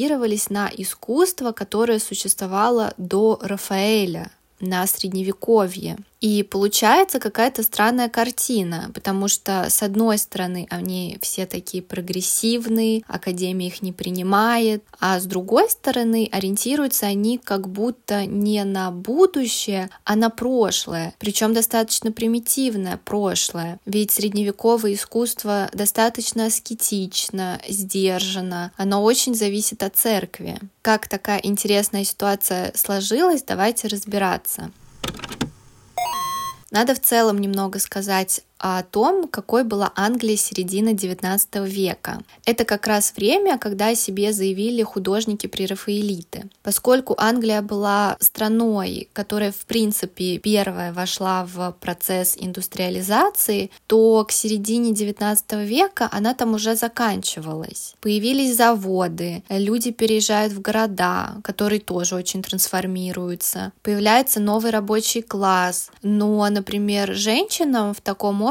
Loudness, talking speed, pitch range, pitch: -21 LUFS, 110 wpm, 195-225 Hz, 205 Hz